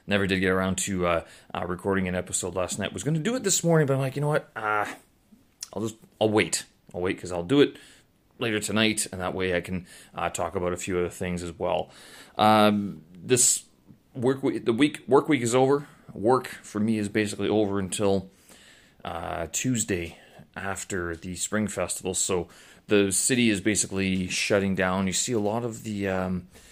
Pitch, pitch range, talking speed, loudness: 100 Hz, 90-110 Hz, 195 wpm, -26 LUFS